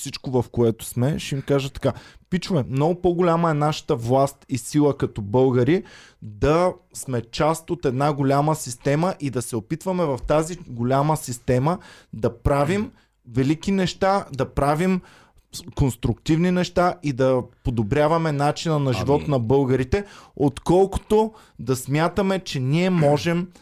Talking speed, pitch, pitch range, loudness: 140 wpm, 145 Hz, 130-170 Hz, -22 LUFS